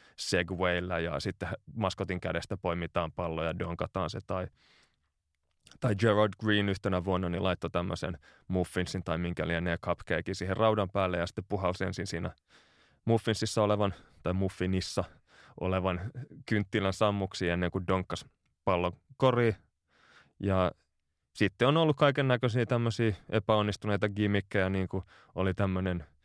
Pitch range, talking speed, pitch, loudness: 85-105 Hz, 130 wpm, 95 Hz, -31 LUFS